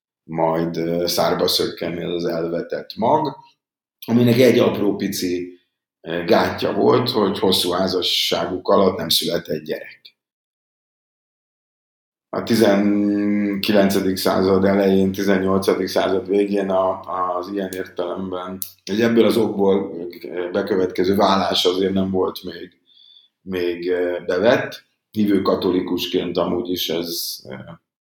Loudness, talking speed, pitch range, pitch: -19 LUFS, 100 wpm, 90-100 Hz, 95 Hz